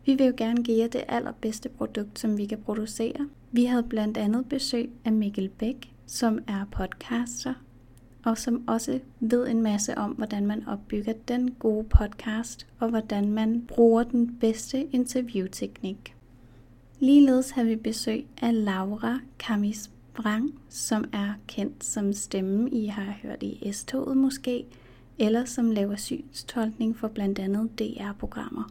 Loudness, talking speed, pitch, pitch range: -27 LUFS, 150 wpm, 225 Hz, 210-245 Hz